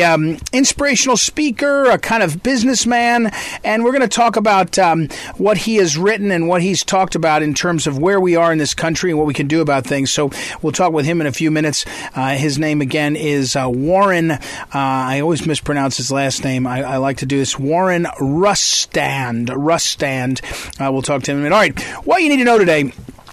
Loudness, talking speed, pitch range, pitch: -15 LUFS, 225 wpm, 140-200 Hz, 160 Hz